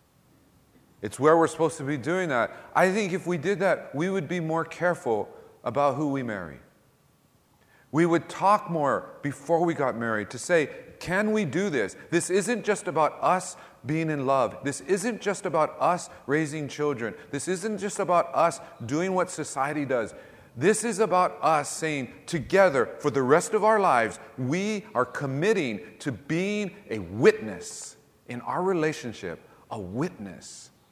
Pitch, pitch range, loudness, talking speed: 165 Hz, 145-190 Hz, -26 LUFS, 165 wpm